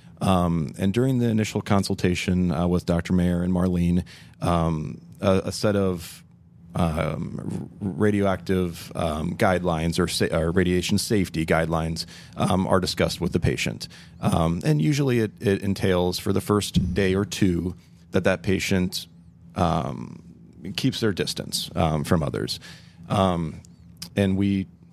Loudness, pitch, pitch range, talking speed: -24 LUFS, 90 Hz, 85-100 Hz, 140 wpm